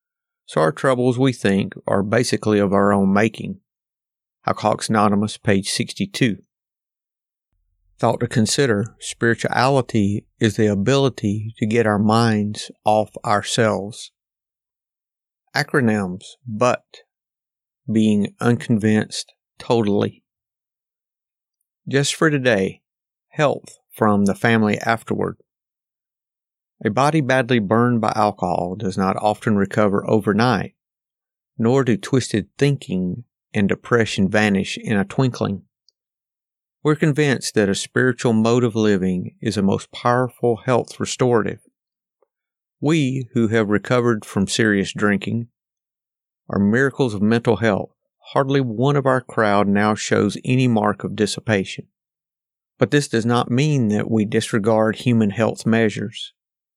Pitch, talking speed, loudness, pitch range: 115 Hz, 115 wpm, -19 LUFS, 105-125 Hz